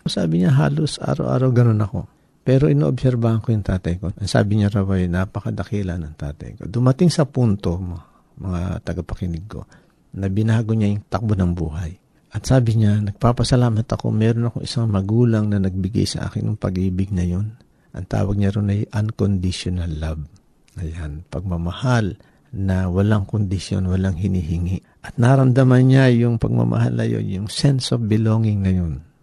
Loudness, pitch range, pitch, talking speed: -20 LUFS, 90-120 Hz, 105 Hz, 160 wpm